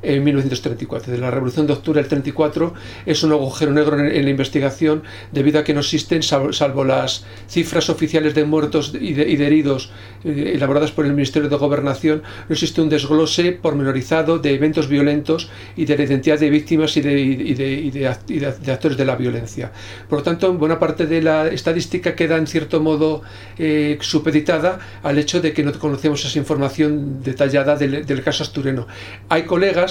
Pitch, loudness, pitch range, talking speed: 150 Hz, -18 LUFS, 140-155 Hz, 190 wpm